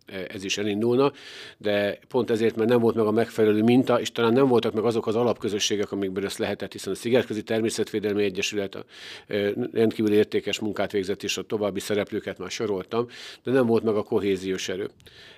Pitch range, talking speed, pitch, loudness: 100-115 Hz, 185 wpm, 110 Hz, -25 LUFS